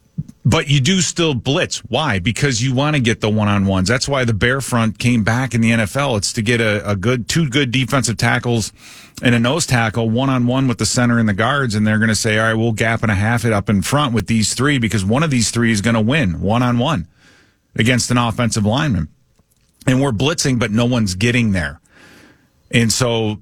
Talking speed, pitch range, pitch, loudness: 240 wpm, 110-130 Hz, 120 Hz, -16 LUFS